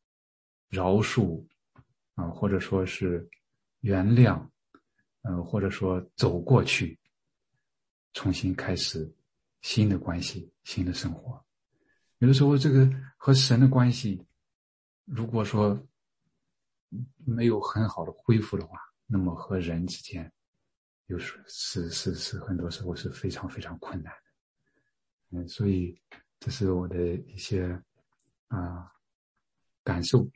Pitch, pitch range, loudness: 95 Hz, 90-115 Hz, -27 LUFS